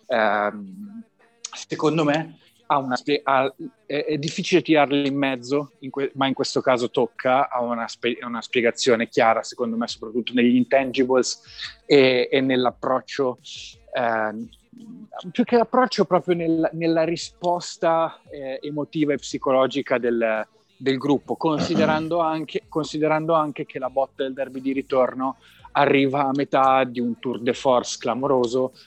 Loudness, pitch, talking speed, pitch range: -22 LUFS, 135 Hz, 135 wpm, 125-160 Hz